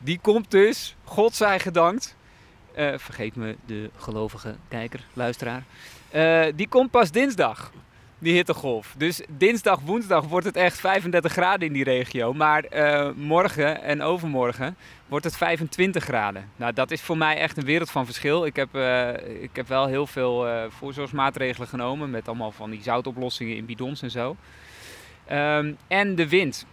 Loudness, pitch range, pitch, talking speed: -24 LUFS, 125-170 Hz, 145 Hz, 165 wpm